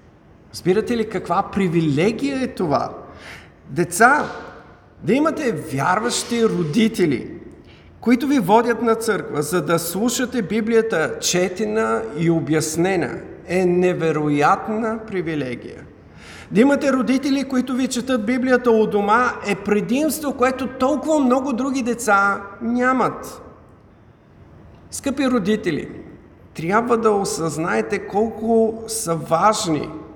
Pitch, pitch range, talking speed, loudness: 220 Hz, 180-245 Hz, 100 wpm, -19 LUFS